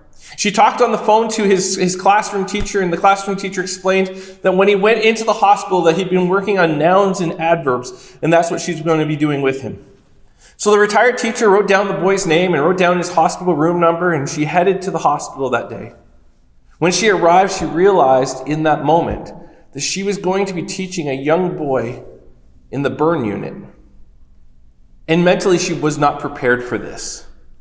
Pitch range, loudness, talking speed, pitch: 150-195 Hz, -15 LUFS, 205 wpm, 175 Hz